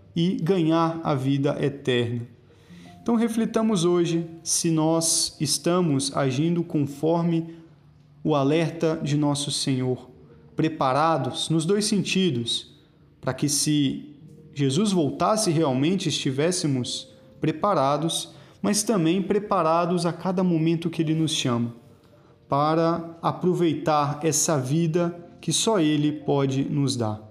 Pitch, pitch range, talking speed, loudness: 160 Hz, 140-170 Hz, 110 wpm, -24 LUFS